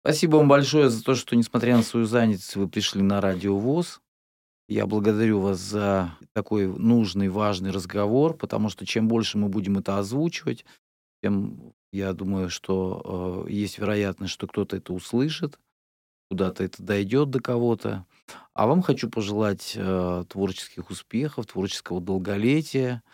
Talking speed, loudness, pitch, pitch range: 145 wpm, -25 LUFS, 105 Hz, 95-120 Hz